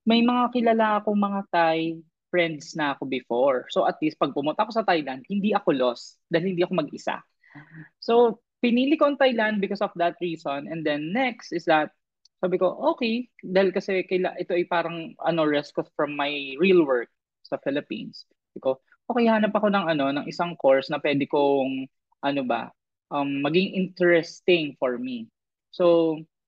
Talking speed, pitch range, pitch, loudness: 170 wpm, 150-210 Hz, 175 Hz, -24 LUFS